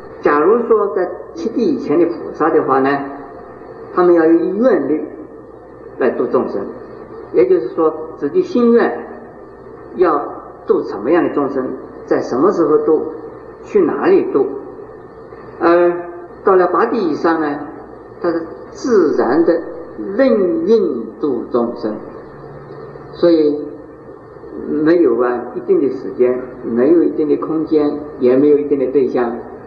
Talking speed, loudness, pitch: 190 characters per minute, -15 LUFS, 365 Hz